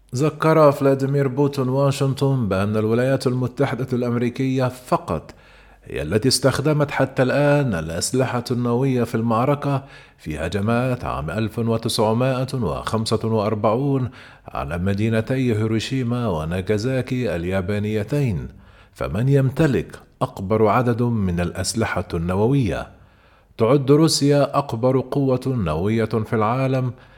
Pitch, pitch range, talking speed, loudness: 125 Hz, 110-135 Hz, 90 wpm, -21 LUFS